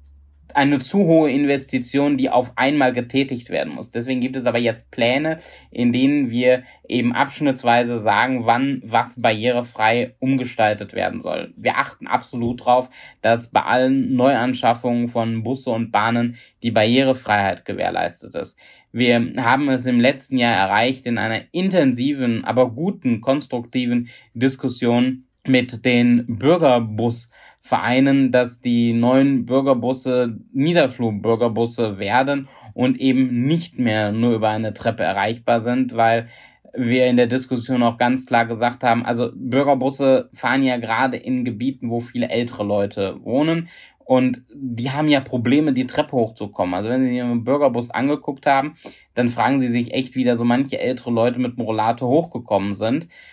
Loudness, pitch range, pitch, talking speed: -19 LUFS, 115-130 Hz, 125 Hz, 145 wpm